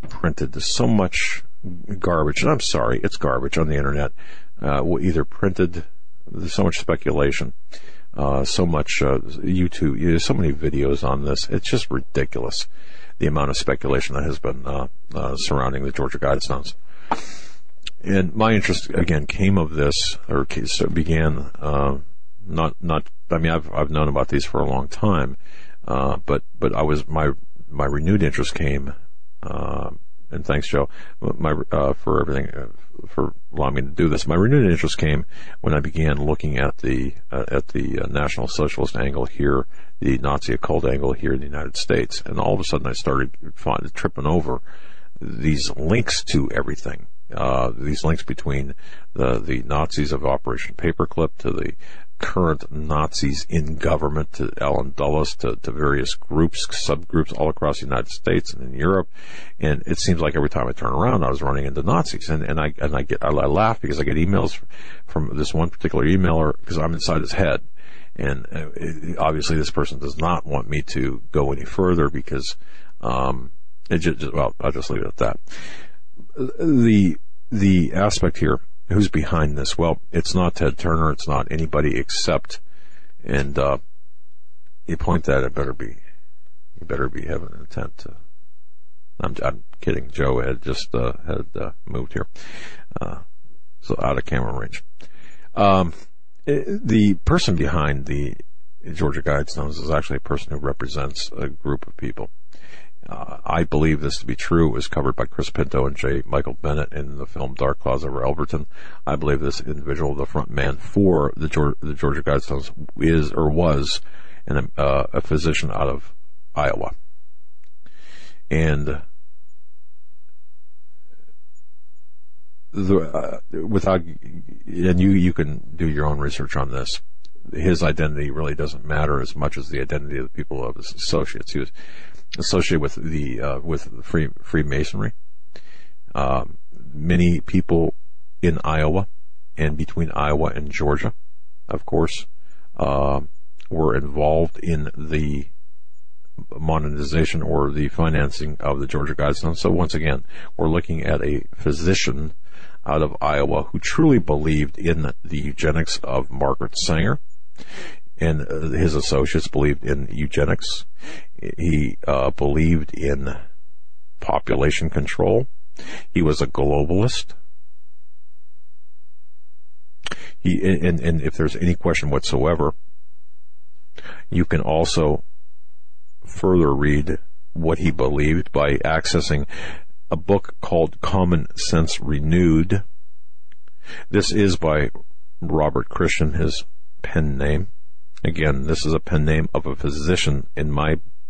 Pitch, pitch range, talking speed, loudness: 75 Hz, 70-80 Hz, 150 wpm, -22 LUFS